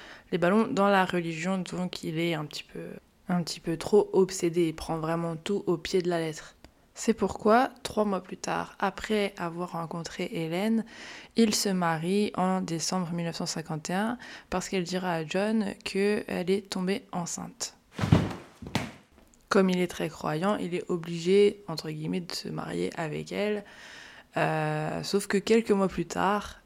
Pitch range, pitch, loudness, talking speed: 170-205 Hz, 185 Hz, -29 LUFS, 160 wpm